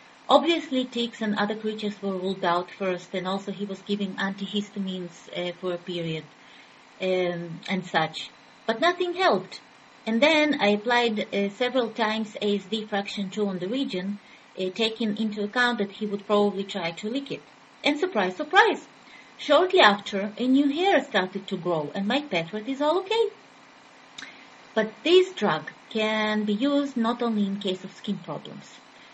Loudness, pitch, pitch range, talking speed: -25 LUFS, 205 Hz, 190-250 Hz, 165 wpm